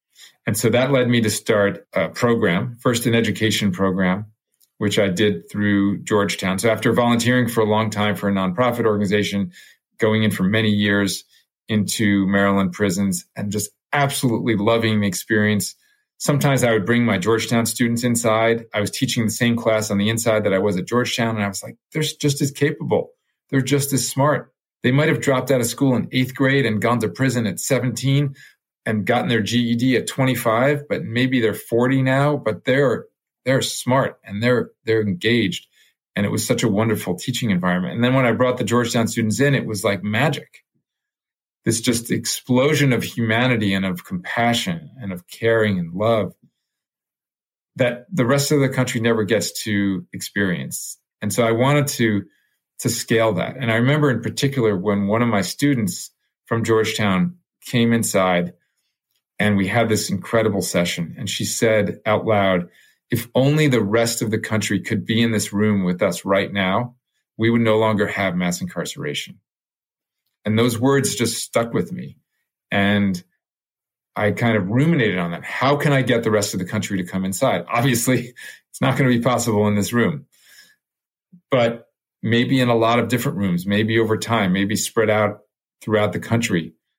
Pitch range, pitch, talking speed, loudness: 105-125 Hz, 115 Hz, 185 wpm, -20 LUFS